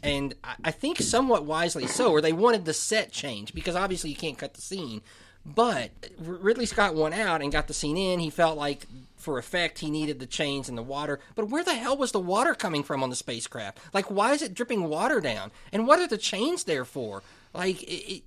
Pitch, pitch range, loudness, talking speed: 160 Hz, 140-215 Hz, -27 LUFS, 230 wpm